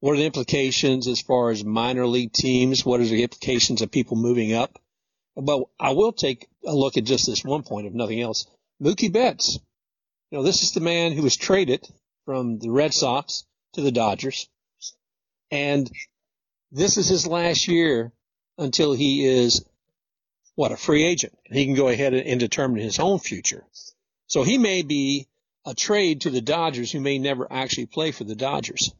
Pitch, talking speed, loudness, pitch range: 135 Hz, 185 wpm, -22 LUFS, 120-160 Hz